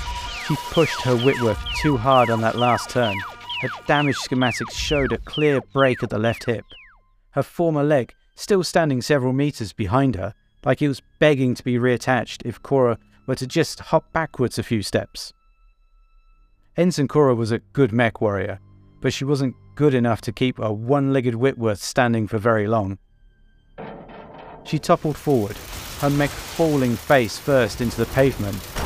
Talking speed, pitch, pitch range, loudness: 170 wpm, 130 Hz, 115-145 Hz, -21 LUFS